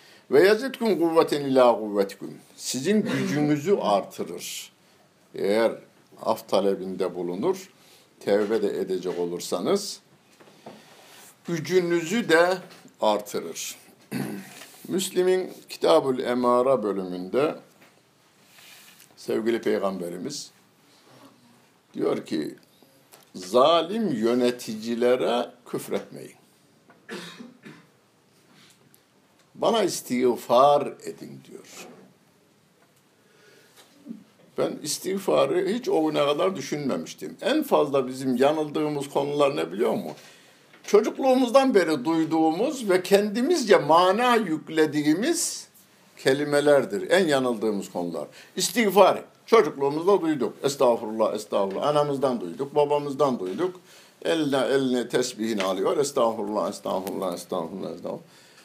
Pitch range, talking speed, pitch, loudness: 125-190 Hz, 80 wpm, 150 Hz, -24 LUFS